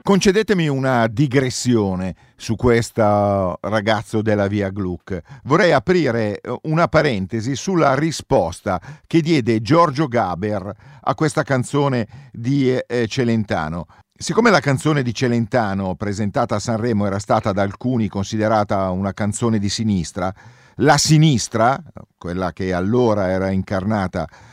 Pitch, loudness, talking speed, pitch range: 115 Hz, -19 LUFS, 115 wpm, 100-140 Hz